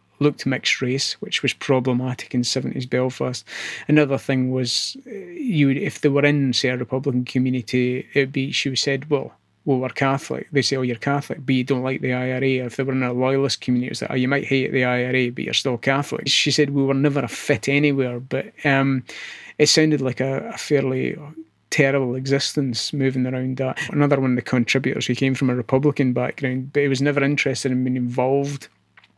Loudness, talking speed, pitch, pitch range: -21 LUFS, 215 wpm, 135 Hz, 125-140 Hz